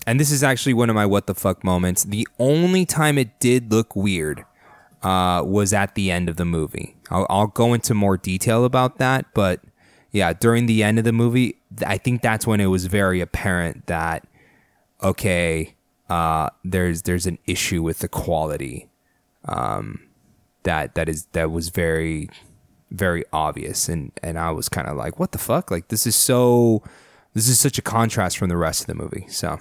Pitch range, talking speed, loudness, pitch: 90-115 Hz, 195 wpm, -21 LUFS, 100 Hz